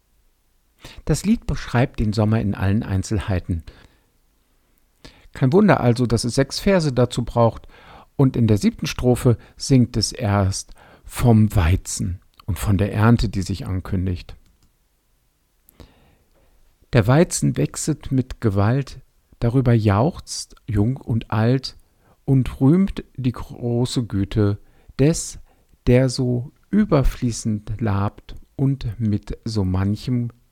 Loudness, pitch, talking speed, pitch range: -20 LUFS, 115 Hz, 115 wpm, 100-125 Hz